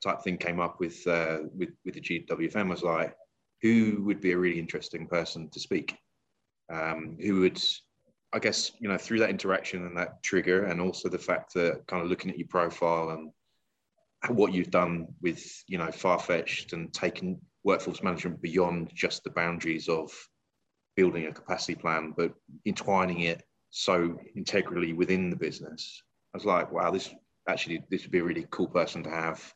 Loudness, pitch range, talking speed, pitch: -30 LUFS, 85-90 Hz, 185 wpm, 85 Hz